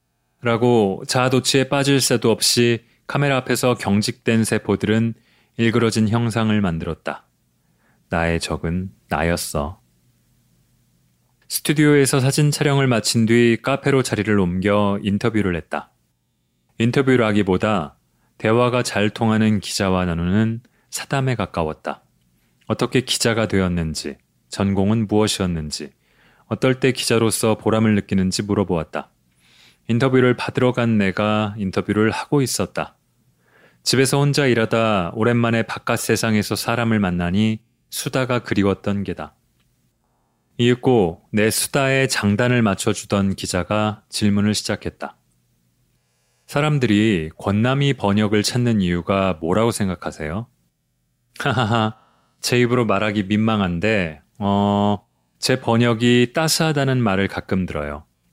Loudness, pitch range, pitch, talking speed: -19 LUFS, 95-120 Hz, 110 Hz, 275 characters per minute